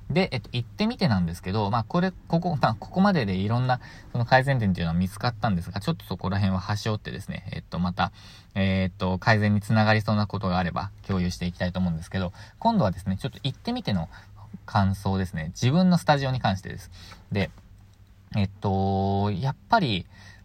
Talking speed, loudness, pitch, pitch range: 440 characters per minute, -26 LUFS, 100 Hz, 95-120 Hz